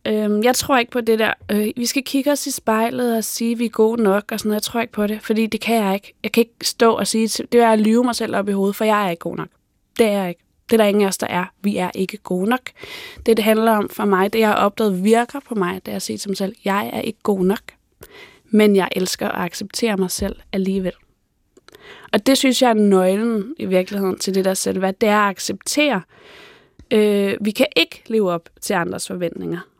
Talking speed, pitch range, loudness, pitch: 260 wpm, 195-230 Hz, -19 LUFS, 215 Hz